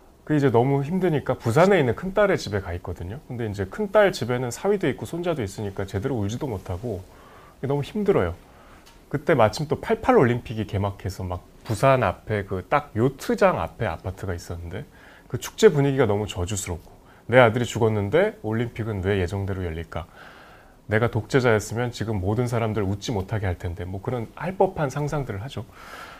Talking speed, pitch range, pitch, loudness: 370 characters per minute, 100-140 Hz, 110 Hz, -24 LUFS